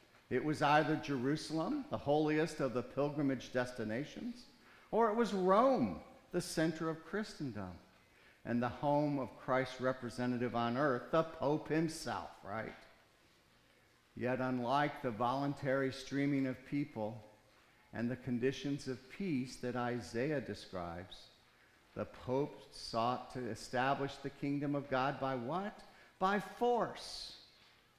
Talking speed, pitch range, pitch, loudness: 125 wpm, 125-155 Hz, 140 Hz, -37 LUFS